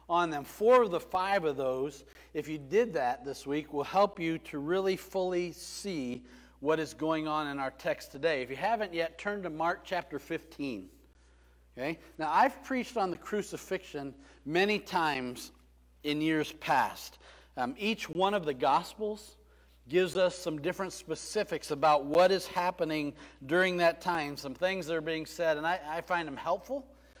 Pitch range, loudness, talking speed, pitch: 145-185 Hz, -32 LUFS, 175 wpm, 165 Hz